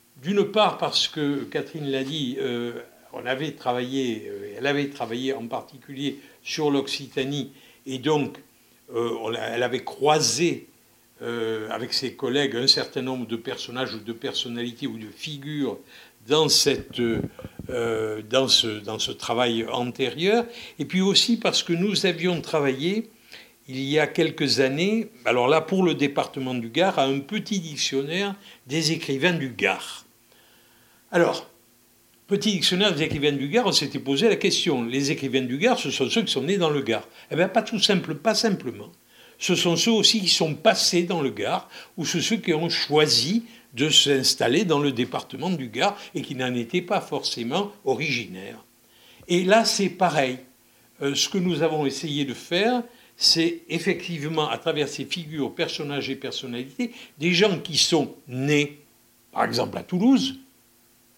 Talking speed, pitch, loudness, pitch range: 165 wpm, 145 Hz, -23 LUFS, 130-180 Hz